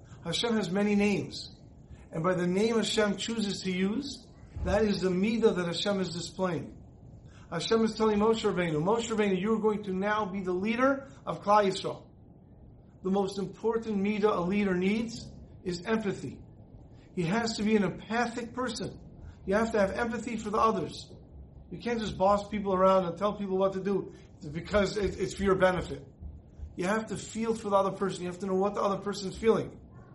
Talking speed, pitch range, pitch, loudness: 195 wpm, 185-215 Hz, 195 Hz, -29 LUFS